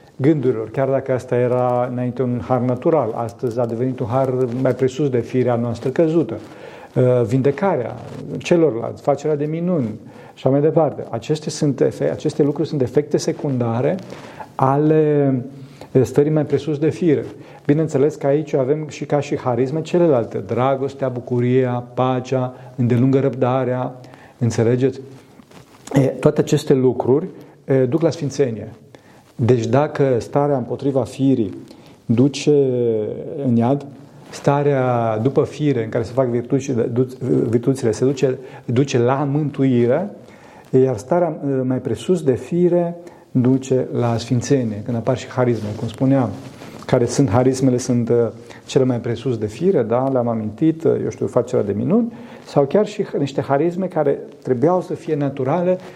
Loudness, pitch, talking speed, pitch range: -19 LUFS, 135 Hz, 140 wpm, 125-150 Hz